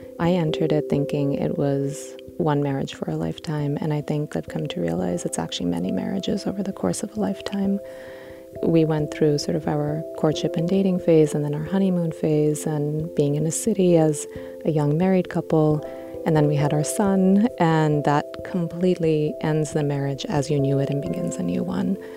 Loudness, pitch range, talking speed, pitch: -23 LUFS, 135-170 Hz, 200 wpm, 150 Hz